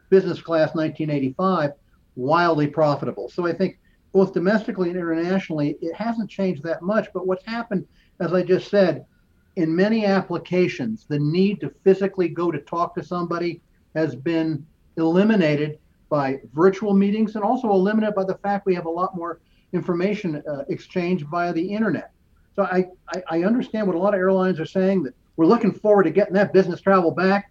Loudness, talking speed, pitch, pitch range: -22 LUFS, 175 wpm, 180 Hz, 165-195 Hz